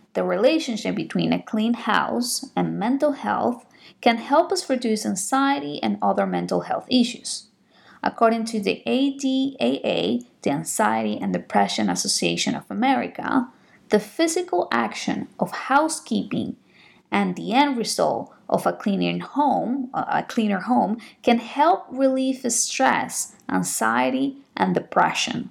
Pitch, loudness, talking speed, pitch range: 240 Hz, -23 LUFS, 120 wpm, 210-270 Hz